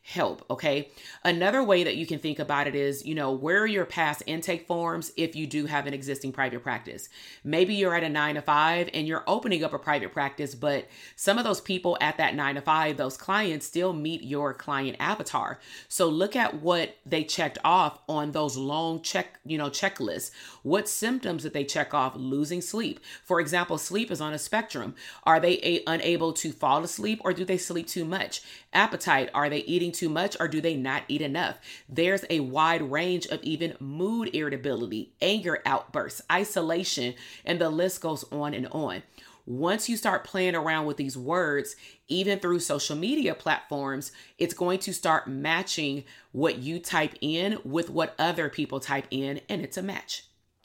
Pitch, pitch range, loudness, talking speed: 160 Hz, 145-180 Hz, -28 LUFS, 195 wpm